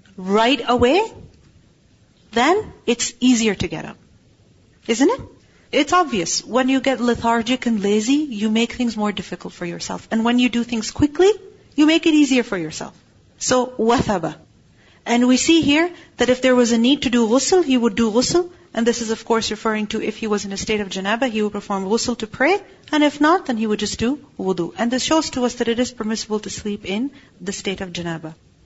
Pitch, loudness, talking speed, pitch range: 235 Hz, -19 LUFS, 215 wpm, 210-265 Hz